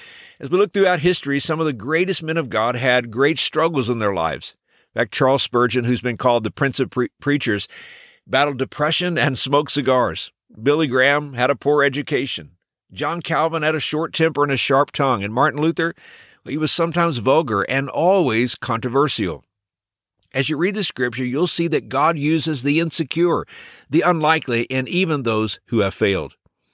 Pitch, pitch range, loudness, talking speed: 145 Hz, 125-160 Hz, -19 LUFS, 185 wpm